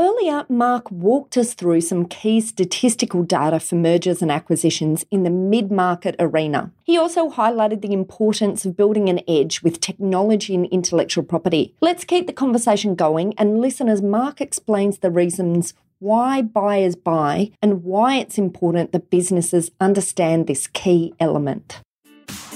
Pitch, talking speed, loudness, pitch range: 190 Hz, 150 wpm, -19 LUFS, 175-220 Hz